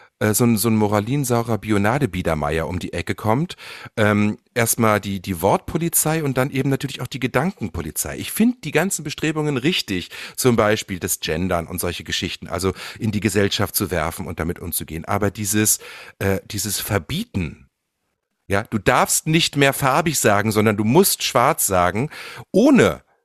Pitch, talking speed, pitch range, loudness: 105 Hz, 160 wpm, 95-135 Hz, -20 LUFS